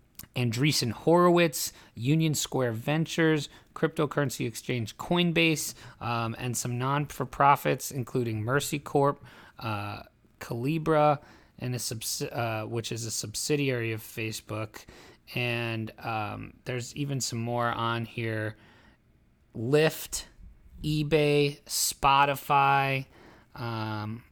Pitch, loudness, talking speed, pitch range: 125 Hz, -28 LUFS, 95 wpm, 115-145 Hz